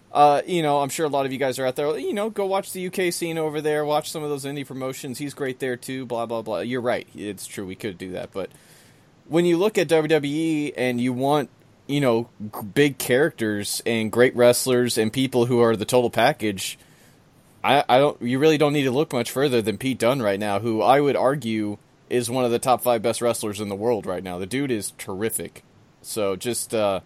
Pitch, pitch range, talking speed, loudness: 125 Hz, 110-145 Hz, 235 wpm, -23 LUFS